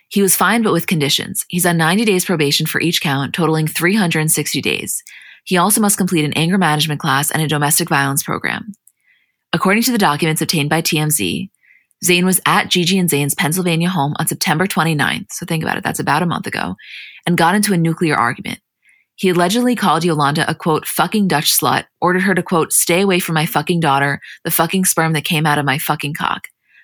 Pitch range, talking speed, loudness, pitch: 150-185 Hz, 205 wpm, -15 LUFS, 165 Hz